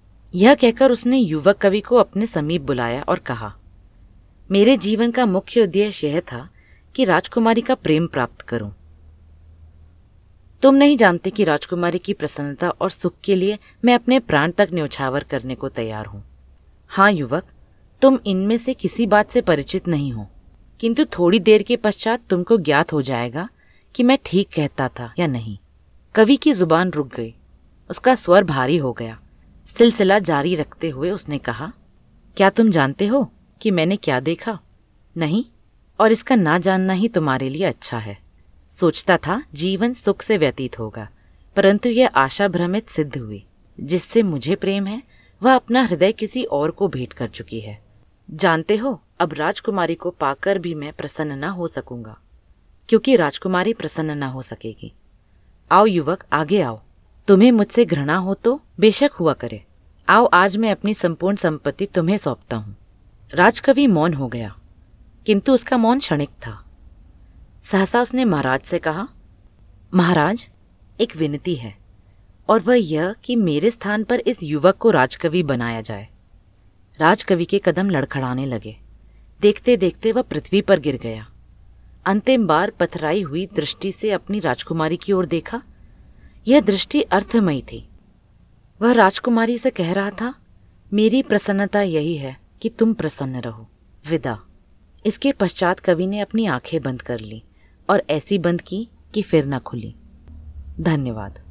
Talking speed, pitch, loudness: 155 wpm, 170 Hz, -19 LUFS